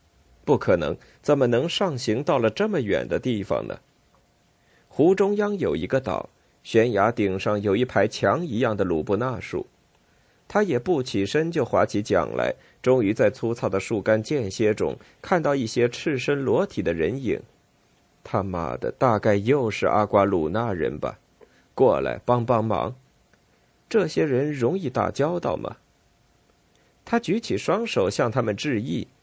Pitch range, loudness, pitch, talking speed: 100-145 Hz, -24 LUFS, 120 Hz, 225 characters per minute